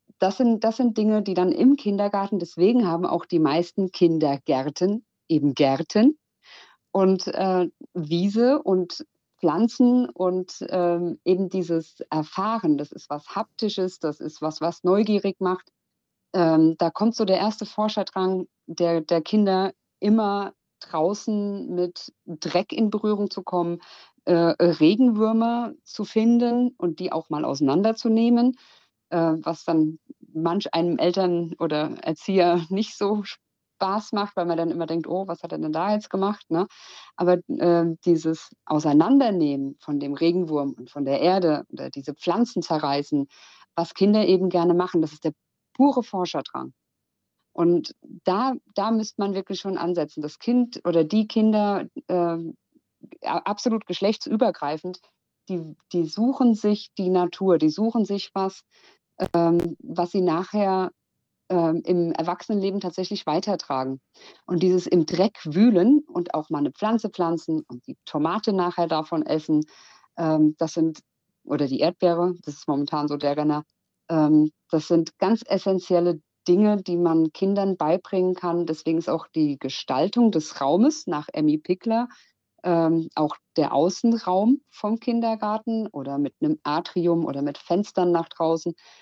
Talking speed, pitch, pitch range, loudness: 145 wpm, 180 Hz, 165-210 Hz, -23 LUFS